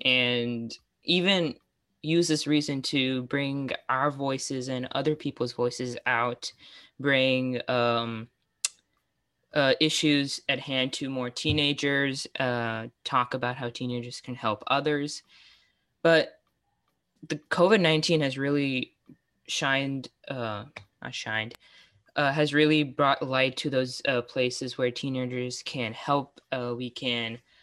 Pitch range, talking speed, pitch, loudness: 125-145 Hz, 125 wpm, 130 Hz, -27 LUFS